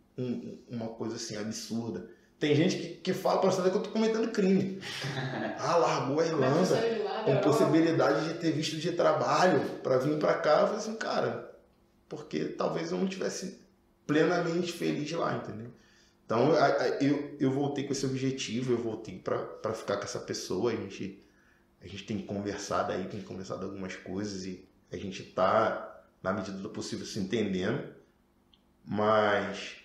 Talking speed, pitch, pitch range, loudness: 160 wpm, 135 Hz, 105-170 Hz, -30 LUFS